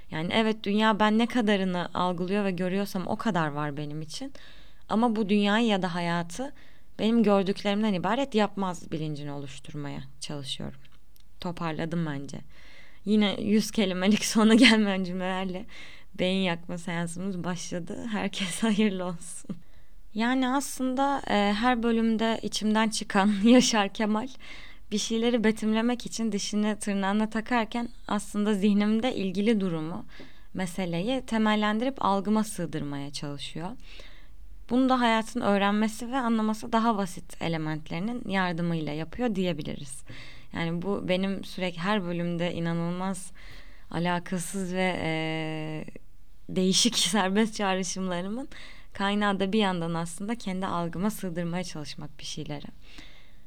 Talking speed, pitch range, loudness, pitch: 115 wpm, 175-220 Hz, -27 LUFS, 195 Hz